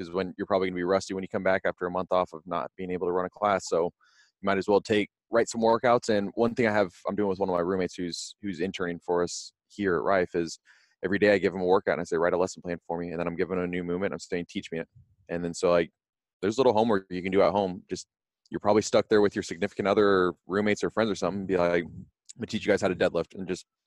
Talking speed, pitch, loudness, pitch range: 305 wpm, 95 Hz, -27 LUFS, 85-100 Hz